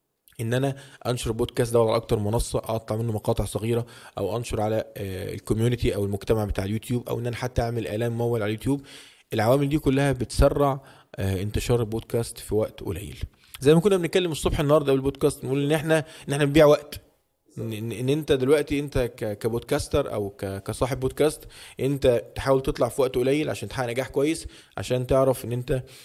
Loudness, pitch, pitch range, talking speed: -25 LUFS, 125 Hz, 110-140 Hz, 170 wpm